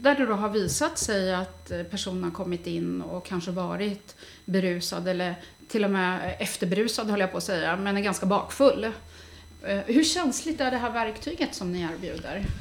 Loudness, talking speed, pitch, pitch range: -27 LUFS, 180 wpm, 200 Hz, 180-225 Hz